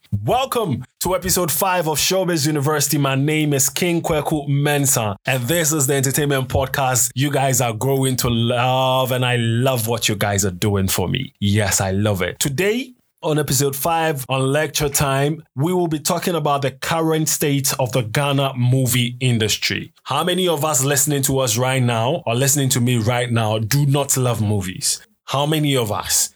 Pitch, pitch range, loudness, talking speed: 135 Hz, 125-155 Hz, -18 LUFS, 185 wpm